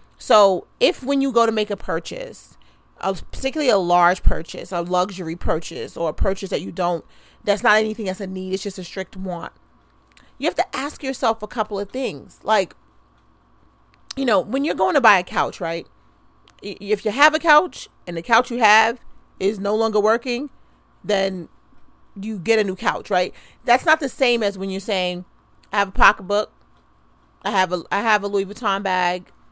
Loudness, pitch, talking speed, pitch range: -20 LUFS, 205 Hz, 195 wpm, 185-235 Hz